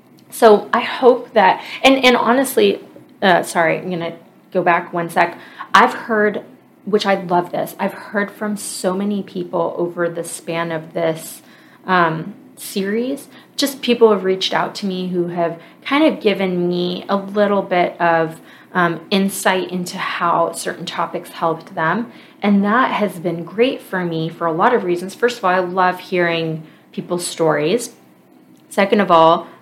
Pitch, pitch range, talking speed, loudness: 185 Hz, 170-210 Hz, 165 wpm, -17 LUFS